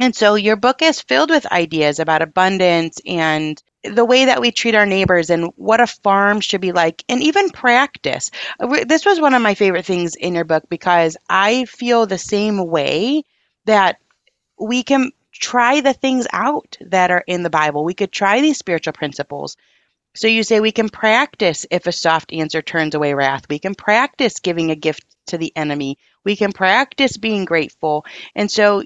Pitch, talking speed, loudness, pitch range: 195 Hz, 190 wpm, -16 LUFS, 165-235 Hz